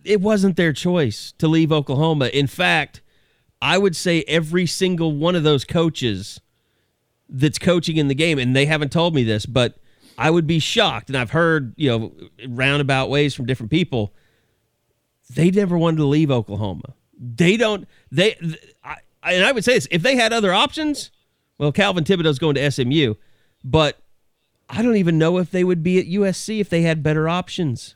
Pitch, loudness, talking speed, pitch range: 155 Hz, -19 LUFS, 180 wpm, 130-175 Hz